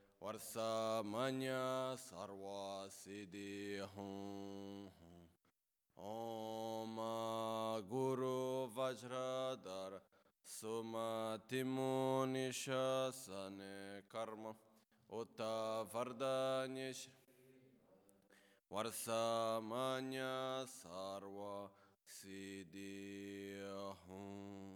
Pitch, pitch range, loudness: 110 Hz, 100-130 Hz, -45 LUFS